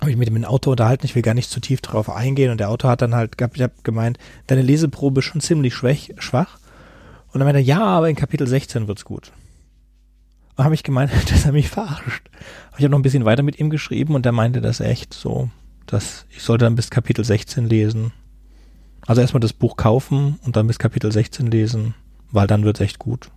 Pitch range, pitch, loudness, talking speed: 110-135 Hz, 120 Hz, -19 LUFS, 230 wpm